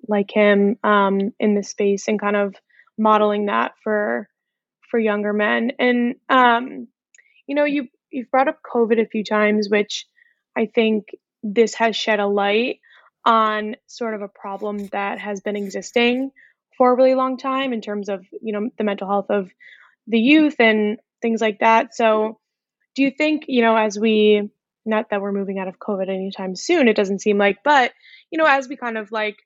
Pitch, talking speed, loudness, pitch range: 220 Hz, 190 wpm, -19 LUFS, 205-245 Hz